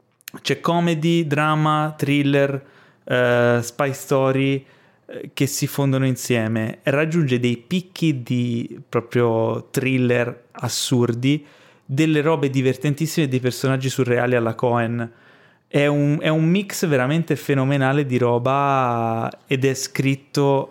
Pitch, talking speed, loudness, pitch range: 135 Hz, 110 wpm, -20 LUFS, 125-150 Hz